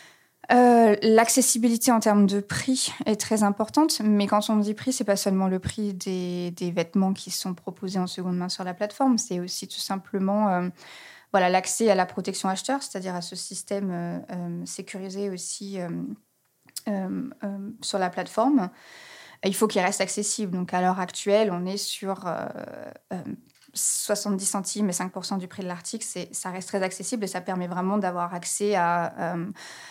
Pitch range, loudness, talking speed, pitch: 185-210 Hz, -25 LUFS, 185 wpm, 195 Hz